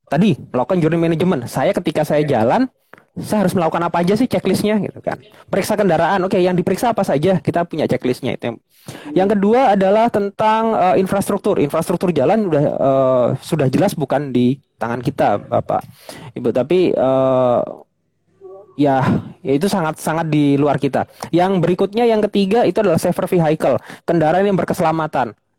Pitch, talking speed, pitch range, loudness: 175 Hz, 160 wpm, 145-195 Hz, -17 LUFS